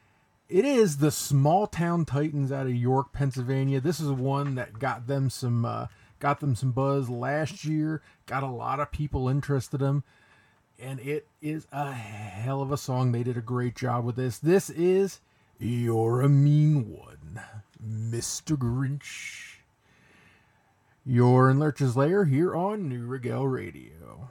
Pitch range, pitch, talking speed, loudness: 120-145 Hz, 135 Hz, 160 wpm, -27 LUFS